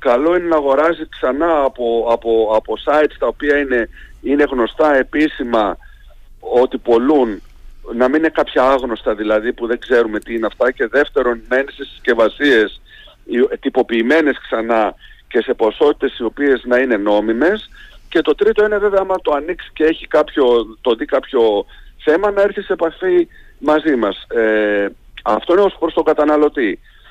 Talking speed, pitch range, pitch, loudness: 160 wpm, 115-165 Hz, 140 Hz, -16 LUFS